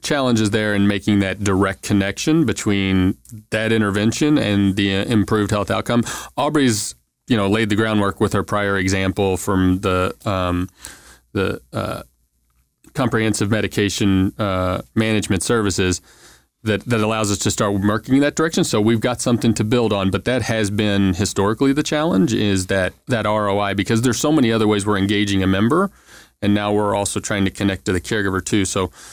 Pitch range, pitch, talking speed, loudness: 95-110 Hz, 105 Hz, 175 wpm, -19 LUFS